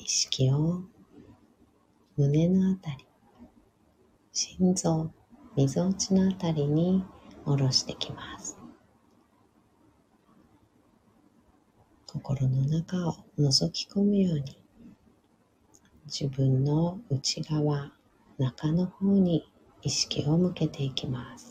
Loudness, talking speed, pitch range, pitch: -28 LUFS, 150 characters per minute, 135-180 Hz, 155 Hz